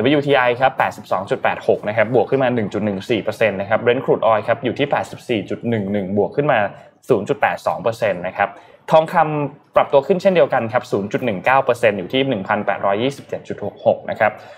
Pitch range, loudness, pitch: 105-145 Hz, -18 LUFS, 125 Hz